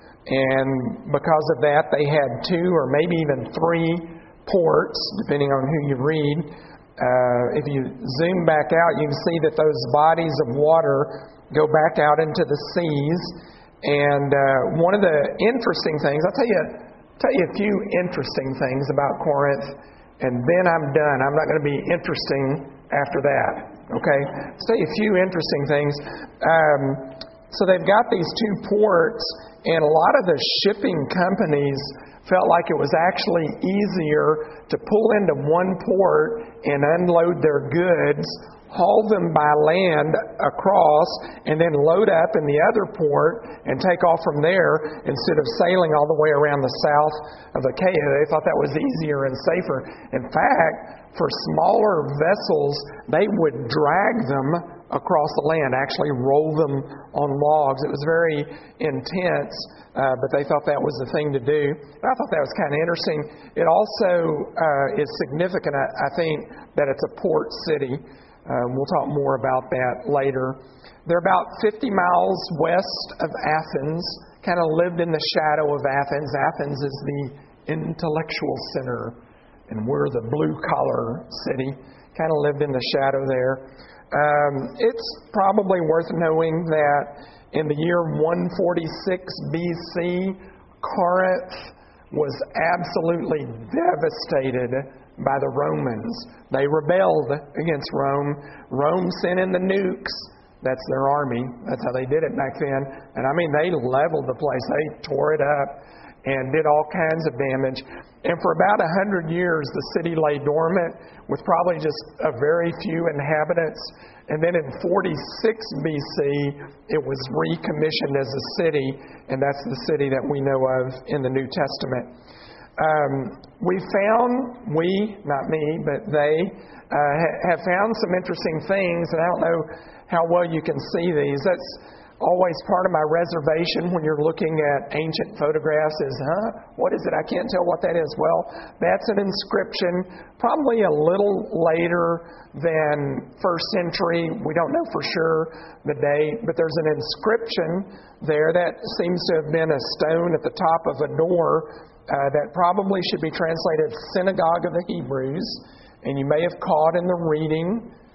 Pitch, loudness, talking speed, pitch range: 155 Hz, -21 LUFS, 160 wpm, 145-175 Hz